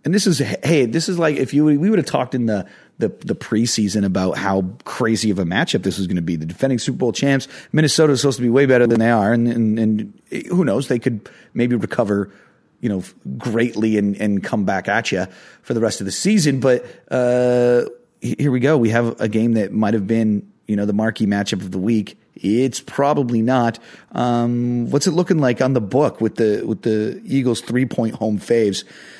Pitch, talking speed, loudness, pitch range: 115 Hz, 225 wpm, -18 LUFS, 105-130 Hz